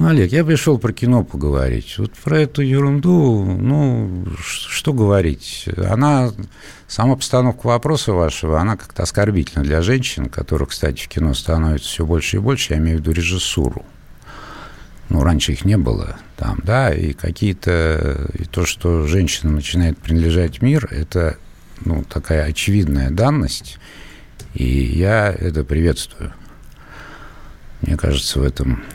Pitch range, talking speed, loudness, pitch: 80-110 Hz, 140 wpm, -18 LUFS, 90 Hz